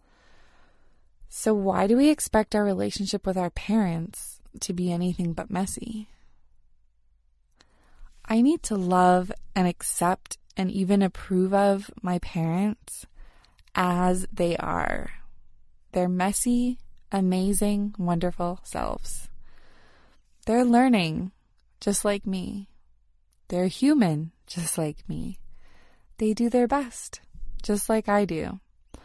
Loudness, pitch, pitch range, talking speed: -25 LUFS, 195 Hz, 180-215 Hz, 110 wpm